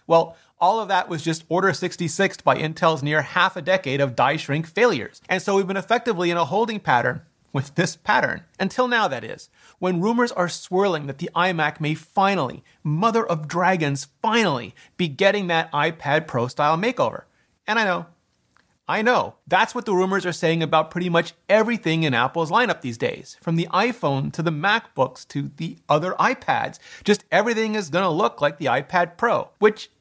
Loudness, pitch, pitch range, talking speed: -22 LUFS, 175 Hz, 155-195 Hz, 190 wpm